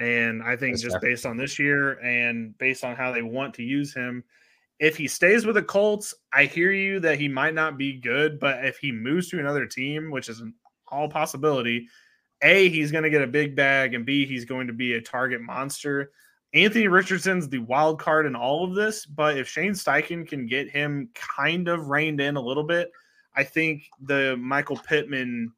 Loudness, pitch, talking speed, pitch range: -24 LUFS, 140 Hz, 210 wpm, 130-155 Hz